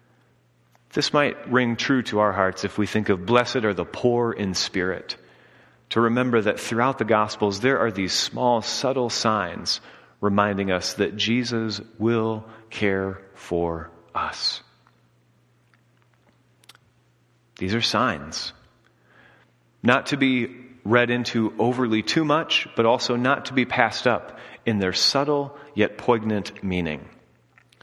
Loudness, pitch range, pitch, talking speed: -23 LUFS, 95-120 Hz, 110 Hz, 130 wpm